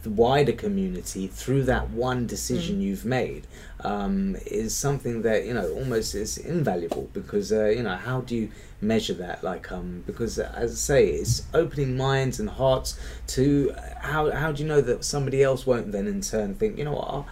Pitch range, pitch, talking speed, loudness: 105-145 Hz, 125 Hz, 195 wpm, -26 LUFS